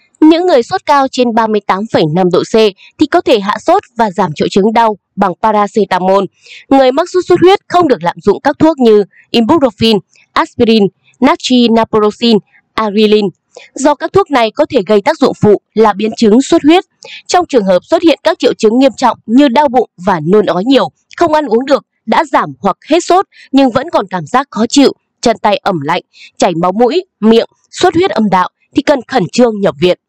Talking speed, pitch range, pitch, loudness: 205 wpm, 210-300 Hz, 235 Hz, -10 LUFS